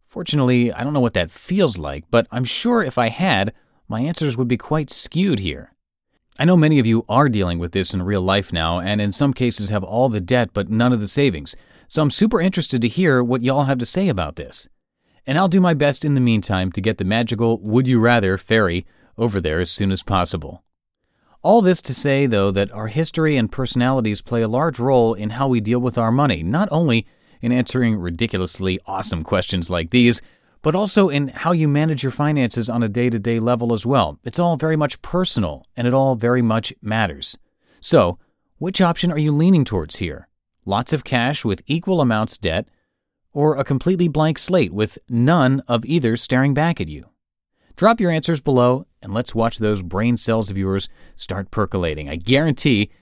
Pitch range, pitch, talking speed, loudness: 105-145 Hz, 120 Hz, 205 wpm, -19 LUFS